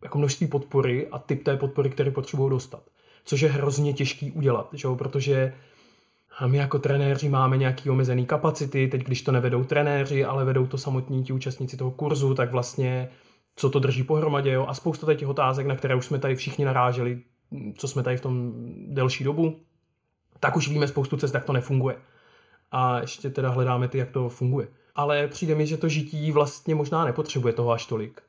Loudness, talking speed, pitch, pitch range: -25 LUFS, 195 wpm, 140 Hz, 130-145 Hz